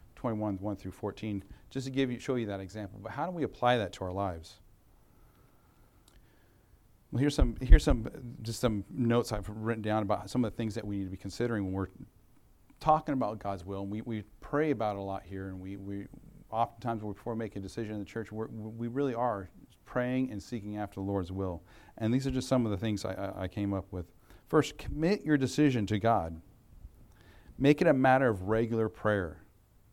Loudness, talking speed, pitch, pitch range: -32 LUFS, 215 wpm, 110 Hz, 100-120 Hz